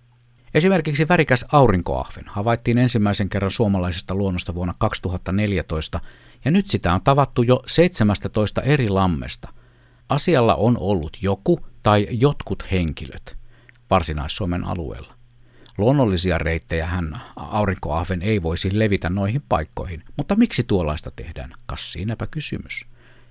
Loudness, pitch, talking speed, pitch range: -21 LUFS, 105 Hz, 115 wpm, 90-120 Hz